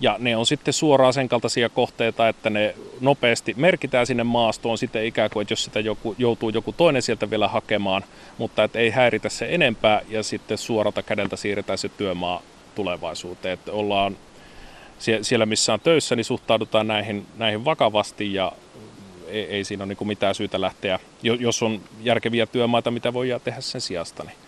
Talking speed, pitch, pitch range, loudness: 165 wpm, 110 Hz, 105-120 Hz, -22 LUFS